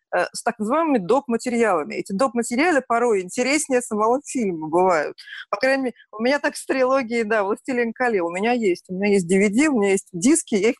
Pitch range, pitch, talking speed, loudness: 205-260 Hz, 235 Hz, 195 wpm, -21 LUFS